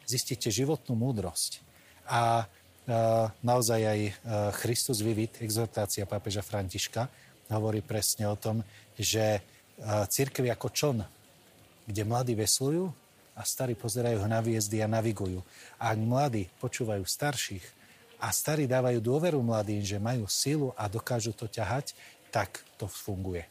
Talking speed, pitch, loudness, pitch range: 135 wpm, 115 Hz, -31 LUFS, 105-125 Hz